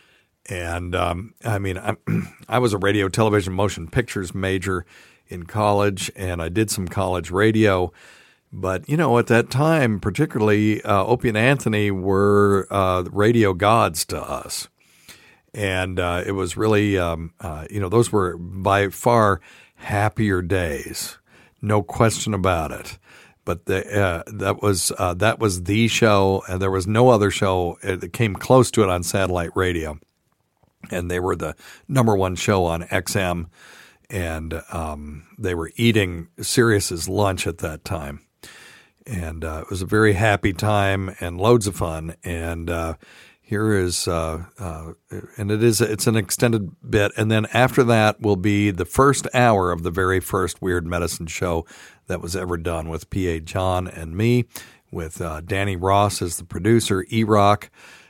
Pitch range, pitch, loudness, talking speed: 90-110 Hz, 95 Hz, -21 LUFS, 165 wpm